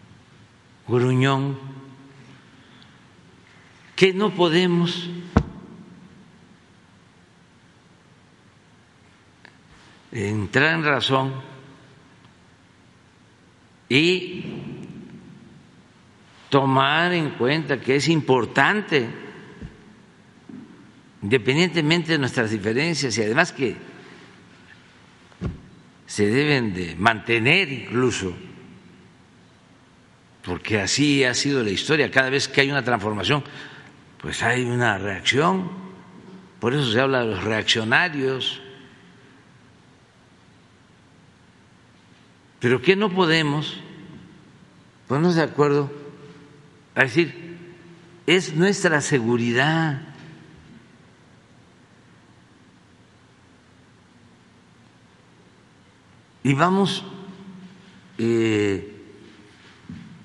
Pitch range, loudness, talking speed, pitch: 120-170 Hz, -21 LUFS, 65 wpm, 140 Hz